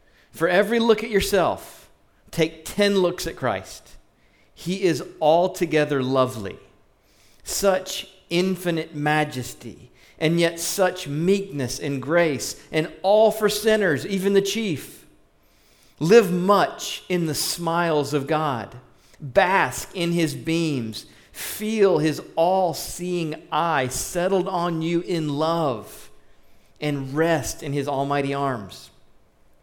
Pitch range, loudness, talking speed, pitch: 140-185 Hz, -22 LUFS, 115 wpm, 165 Hz